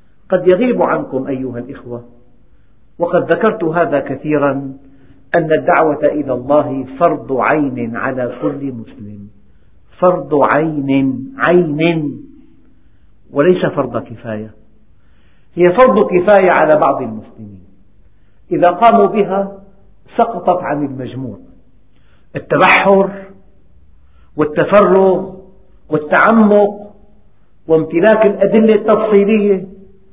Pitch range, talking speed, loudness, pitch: 120-190 Hz, 85 wpm, -13 LUFS, 150 Hz